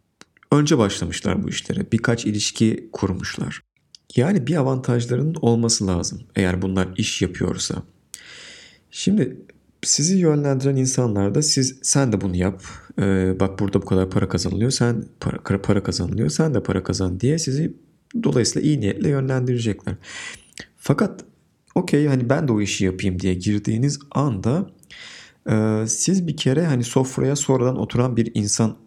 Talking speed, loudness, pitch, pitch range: 140 wpm, -21 LUFS, 115 Hz, 100-135 Hz